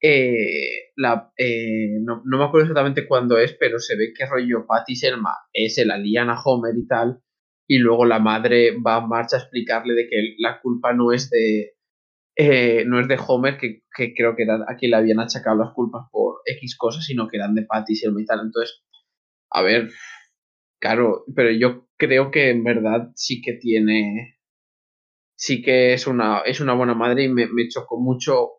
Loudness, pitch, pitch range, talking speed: -20 LUFS, 120 Hz, 115-130 Hz, 195 wpm